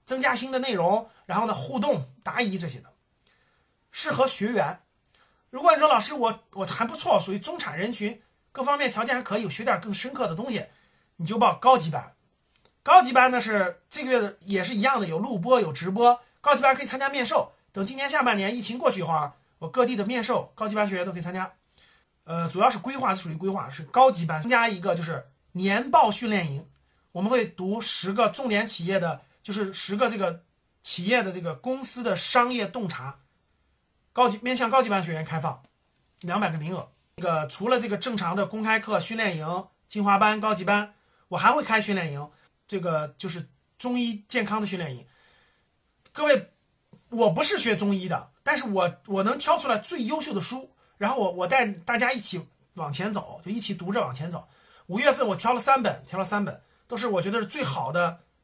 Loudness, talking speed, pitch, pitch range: -23 LUFS, 300 characters per minute, 205 Hz, 180-245 Hz